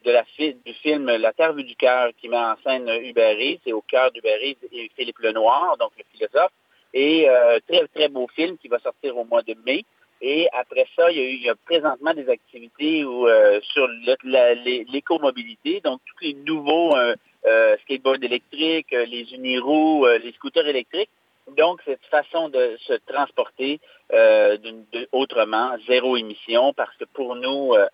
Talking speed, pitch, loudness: 190 wpm, 170 Hz, -21 LUFS